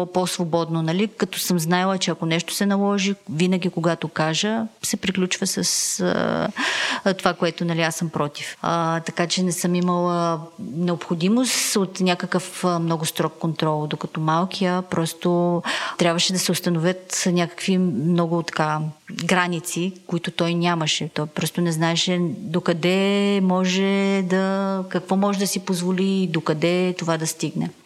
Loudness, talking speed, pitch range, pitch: -22 LUFS, 140 wpm, 165-190 Hz, 180 Hz